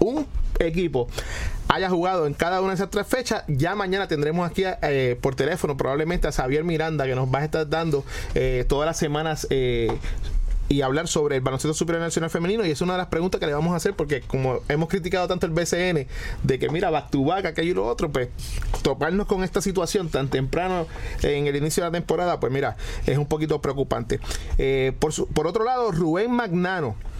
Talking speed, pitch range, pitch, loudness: 210 wpm, 140-180 Hz, 160 Hz, -24 LUFS